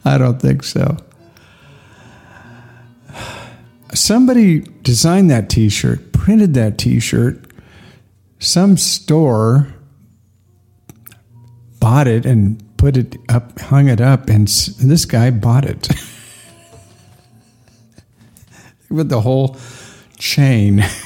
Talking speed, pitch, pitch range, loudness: 95 wpm, 120 Hz, 110-140 Hz, -13 LUFS